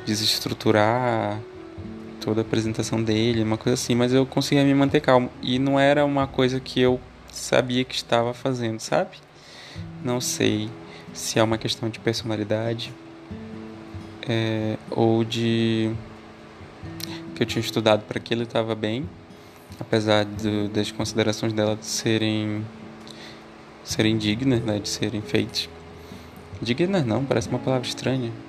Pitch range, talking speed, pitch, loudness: 110-125 Hz, 135 wpm, 110 Hz, -23 LUFS